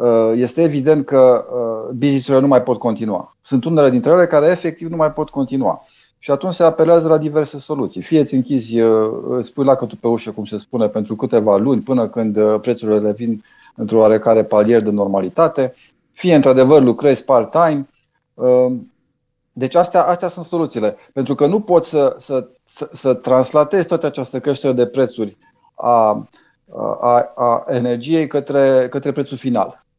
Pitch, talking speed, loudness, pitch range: 130 Hz, 160 wpm, -16 LUFS, 120-150 Hz